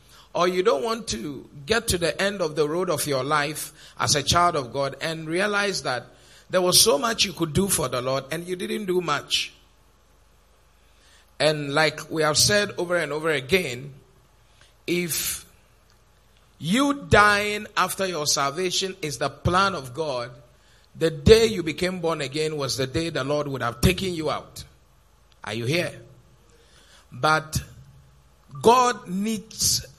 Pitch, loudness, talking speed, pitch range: 150 Hz, -23 LUFS, 160 wpm, 120-180 Hz